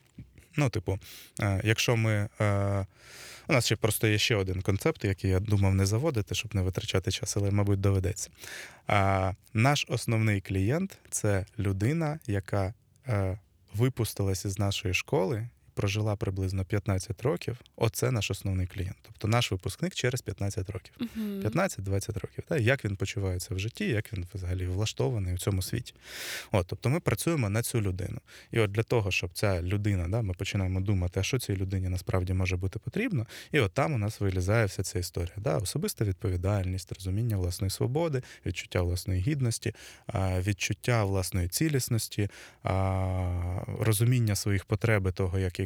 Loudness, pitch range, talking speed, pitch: -30 LUFS, 95-115 Hz, 150 wpm, 105 Hz